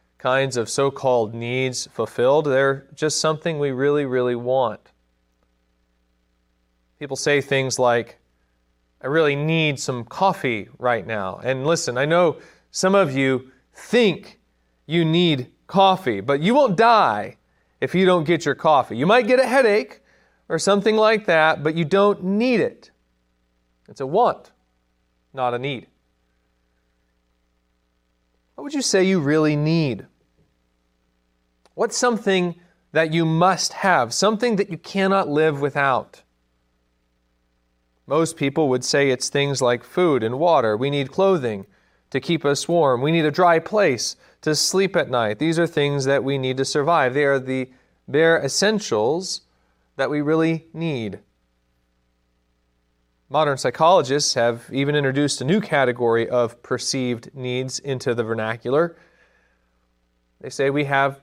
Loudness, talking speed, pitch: -20 LUFS, 140 wpm, 135 Hz